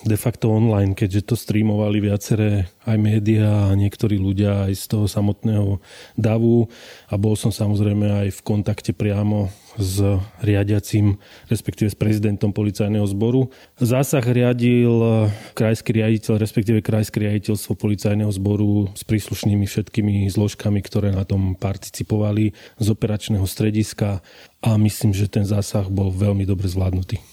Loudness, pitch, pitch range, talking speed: -20 LUFS, 105 Hz, 100-110 Hz, 135 wpm